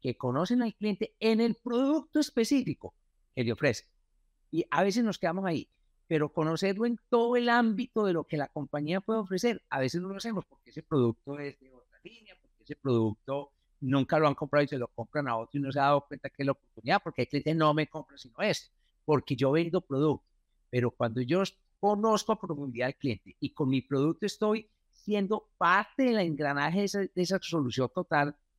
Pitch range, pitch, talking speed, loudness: 135-205 Hz, 155 Hz, 210 wpm, -30 LUFS